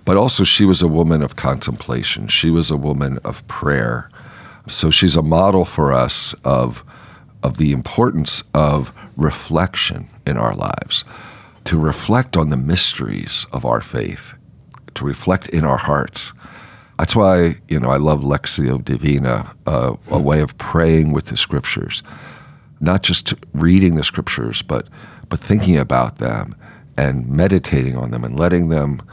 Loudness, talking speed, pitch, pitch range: -17 LUFS, 155 wpm, 80 Hz, 70-90 Hz